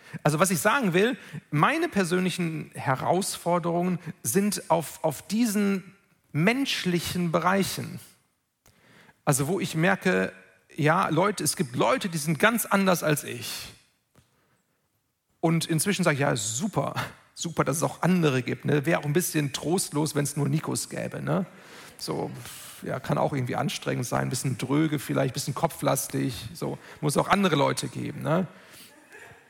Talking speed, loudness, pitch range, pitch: 155 wpm, -26 LUFS, 150-185 Hz, 165 Hz